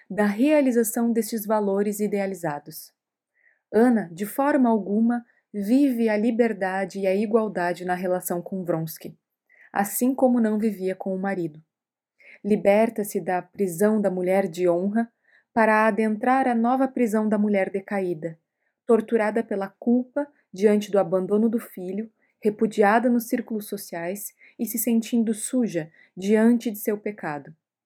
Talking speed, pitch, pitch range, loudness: 130 wpm, 210 Hz, 195-235 Hz, -24 LUFS